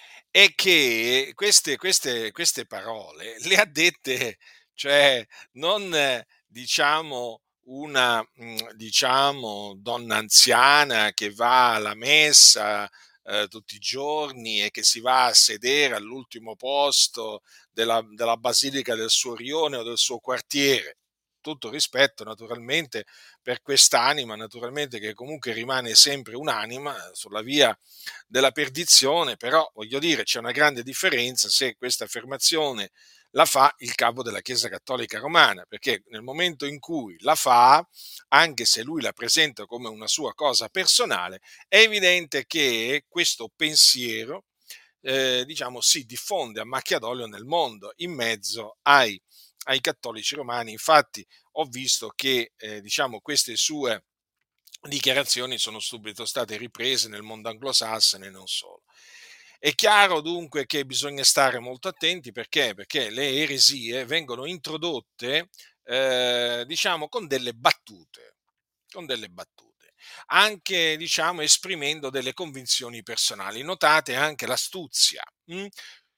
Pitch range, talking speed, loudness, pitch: 115-155 Hz, 130 wpm, -21 LUFS, 135 Hz